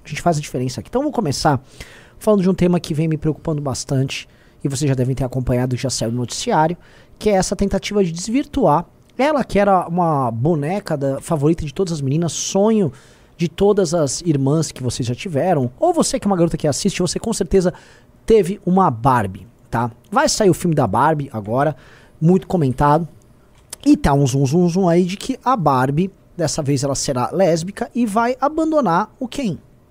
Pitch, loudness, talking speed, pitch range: 165 Hz, -18 LUFS, 200 wpm, 135-195 Hz